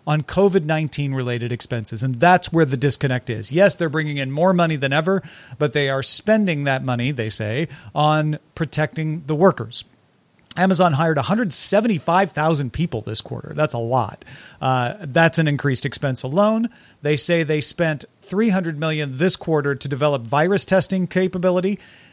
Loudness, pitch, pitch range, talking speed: -20 LUFS, 155 Hz, 135-180 Hz, 185 wpm